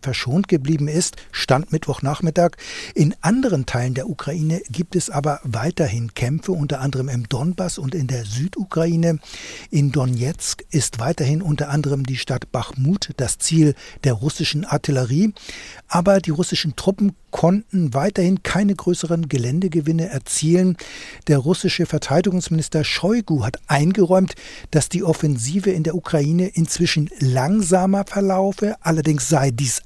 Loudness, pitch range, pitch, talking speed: -20 LUFS, 140-180 Hz, 160 Hz, 130 wpm